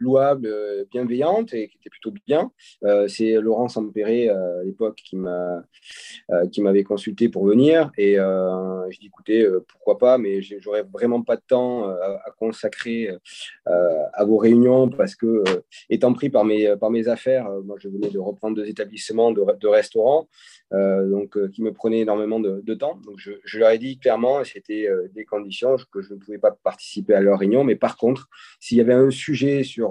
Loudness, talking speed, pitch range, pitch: -21 LUFS, 205 wpm, 100-125 Hz, 110 Hz